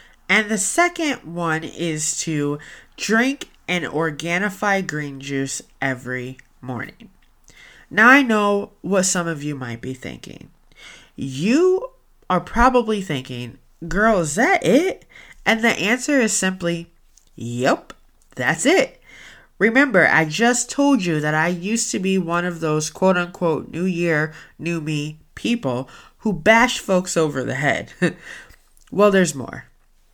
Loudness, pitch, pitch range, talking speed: -19 LUFS, 175 Hz, 150-215 Hz, 135 wpm